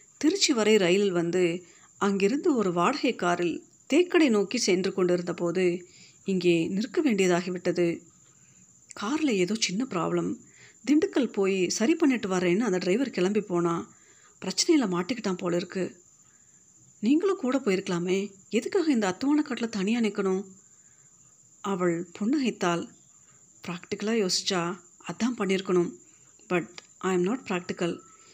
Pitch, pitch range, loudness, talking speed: 190 Hz, 175-240 Hz, -27 LUFS, 110 wpm